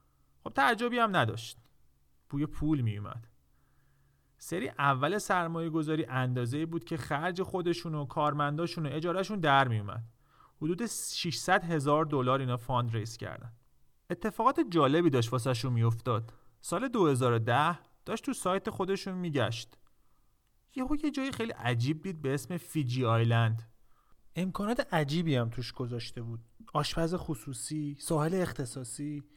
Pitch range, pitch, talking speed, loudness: 120-170 Hz, 145 Hz, 135 wpm, -31 LUFS